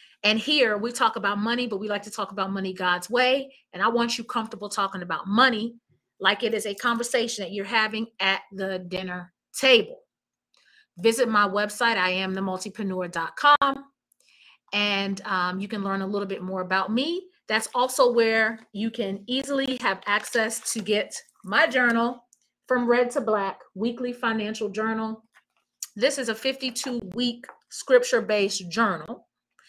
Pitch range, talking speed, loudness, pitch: 195-245 Hz, 160 wpm, -25 LUFS, 220 Hz